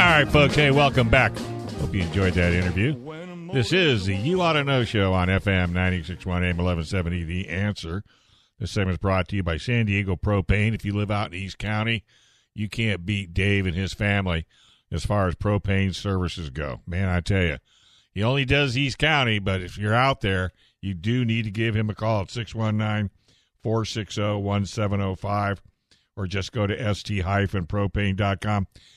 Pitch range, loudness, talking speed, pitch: 95-115 Hz, -24 LUFS, 175 wpm, 100 Hz